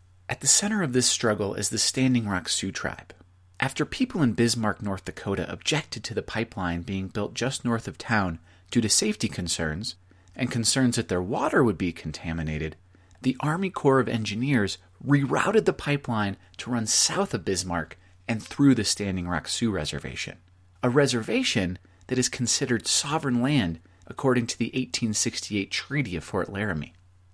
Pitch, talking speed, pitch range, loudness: 105 Hz, 165 wpm, 90-125 Hz, -26 LUFS